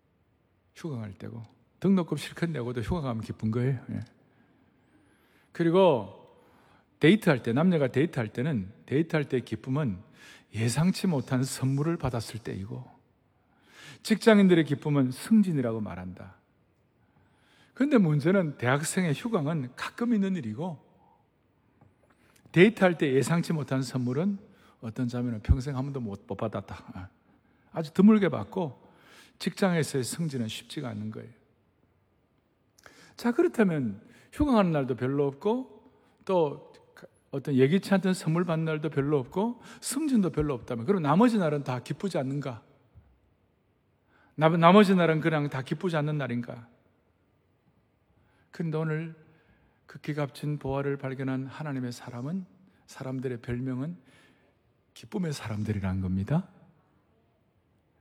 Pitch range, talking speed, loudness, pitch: 120-170 Hz, 270 characters per minute, -28 LUFS, 145 Hz